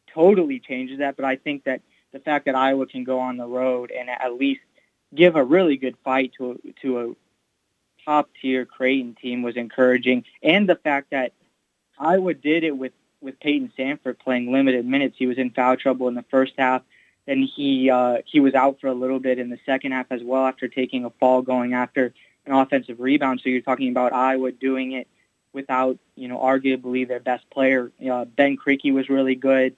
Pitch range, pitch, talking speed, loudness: 125-135 Hz, 130 Hz, 205 wpm, -22 LUFS